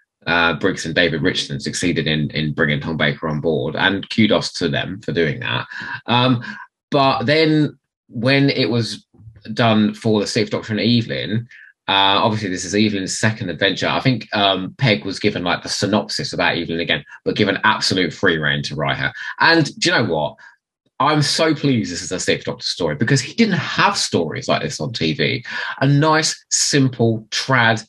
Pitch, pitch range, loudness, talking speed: 110 Hz, 85-130 Hz, -18 LUFS, 185 wpm